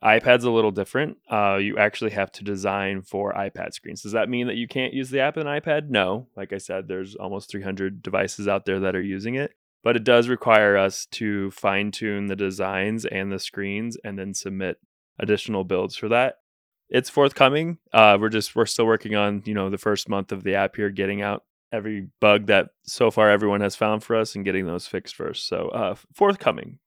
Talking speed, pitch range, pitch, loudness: 215 wpm, 100-115 Hz, 105 Hz, -23 LUFS